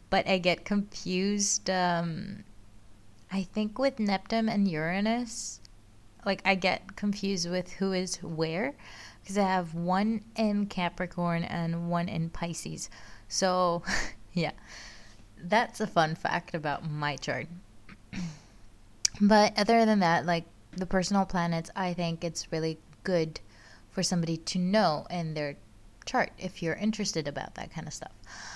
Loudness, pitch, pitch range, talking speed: -30 LUFS, 175 Hz, 155-195 Hz, 140 wpm